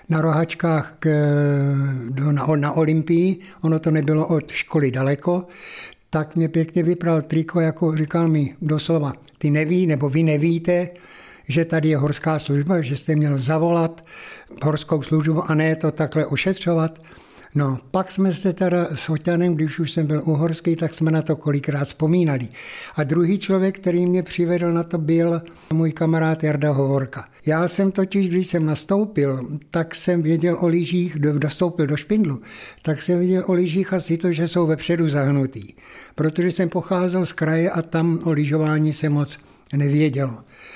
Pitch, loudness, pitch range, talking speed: 160 Hz, -21 LUFS, 150-175 Hz, 160 wpm